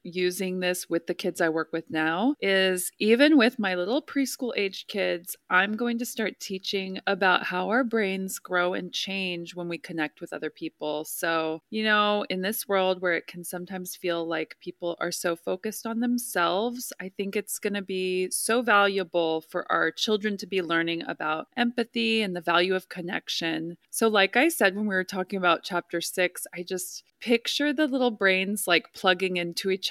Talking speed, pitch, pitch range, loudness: 190 wpm, 185 Hz, 175-215 Hz, -26 LUFS